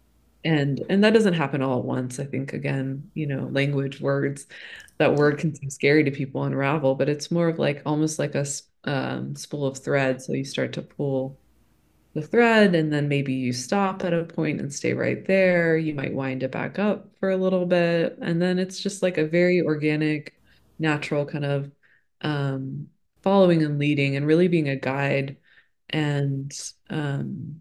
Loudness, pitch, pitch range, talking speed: -24 LUFS, 145 Hz, 140-170 Hz, 185 wpm